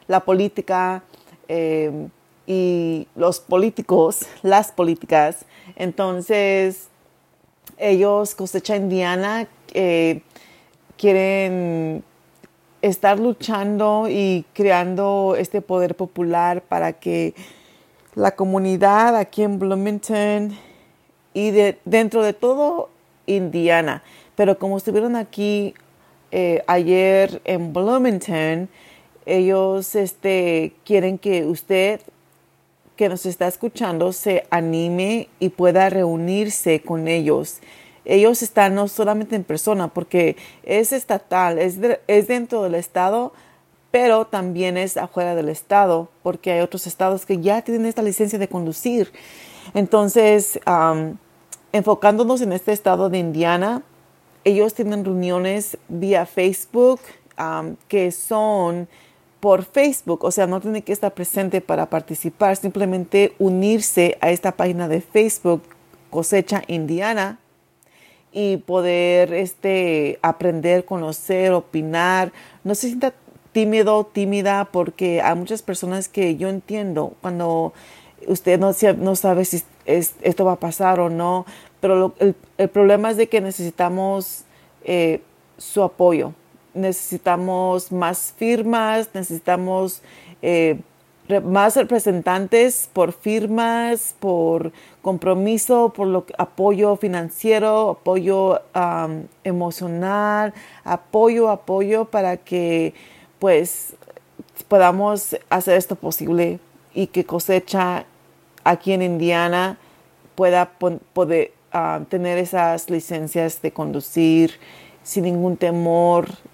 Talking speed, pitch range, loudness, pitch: 110 wpm, 175-205 Hz, -19 LUFS, 185 Hz